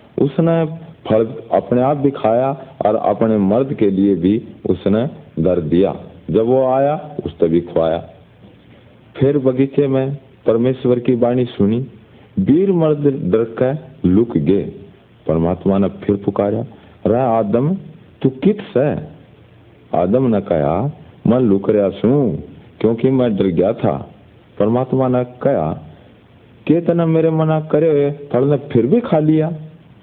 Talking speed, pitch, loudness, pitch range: 140 wpm, 130 Hz, -16 LUFS, 110-150 Hz